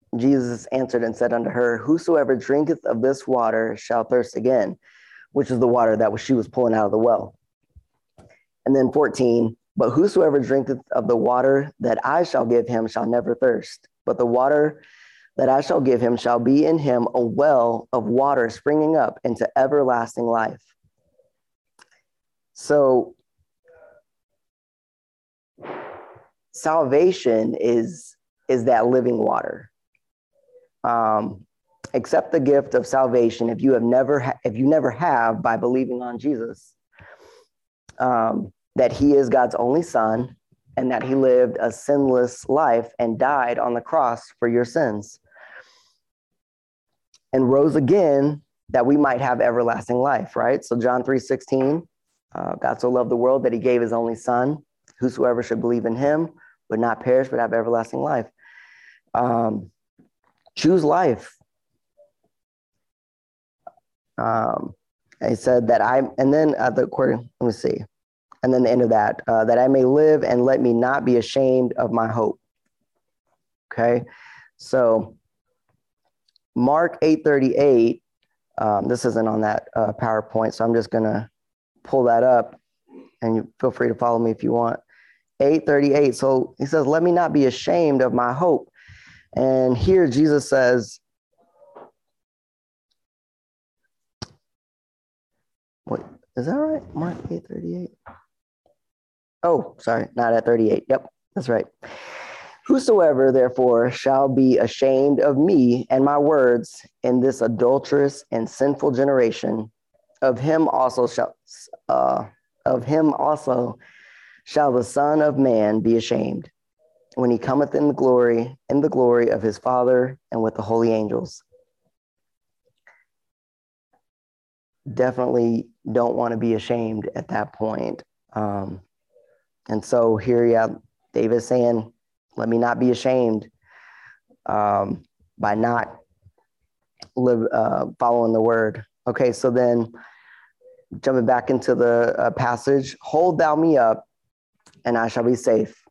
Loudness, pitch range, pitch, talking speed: -20 LUFS, 115-135 Hz, 125 Hz, 140 wpm